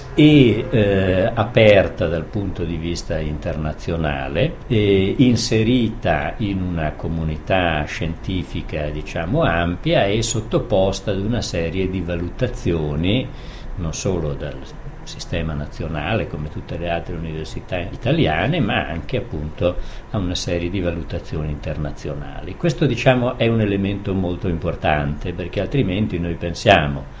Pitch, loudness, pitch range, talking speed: 90 Hz, -20 LUFS, 80-110 Hz, 115 wpm